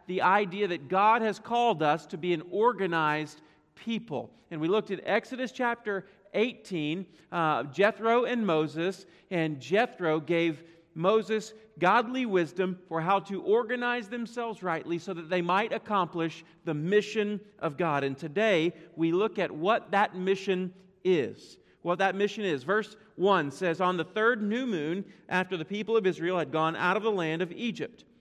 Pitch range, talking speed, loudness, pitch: 165-215 Hz, 165 wpm, -29 LUFS, 190 Hz